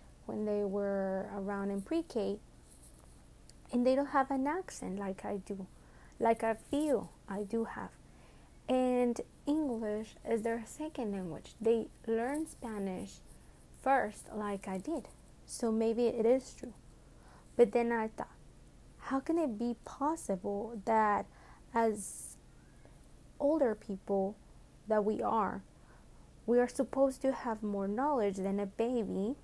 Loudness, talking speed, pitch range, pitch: -35 LUFS, 135 wpm, 200-245 Hz, 220 Hz